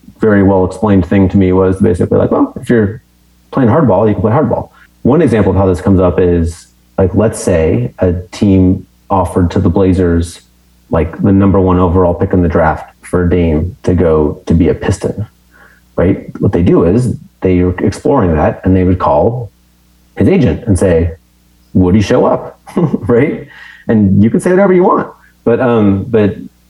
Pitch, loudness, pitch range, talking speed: 90 Hz, -11 LUFS, 85-100 Hz, 185 wpm